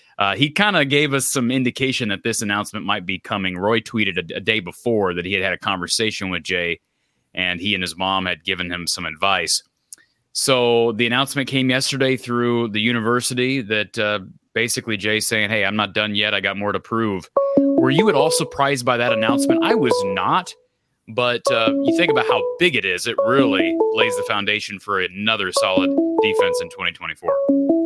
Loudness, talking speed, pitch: -19 LUFS, 200 wpm, 120 Hz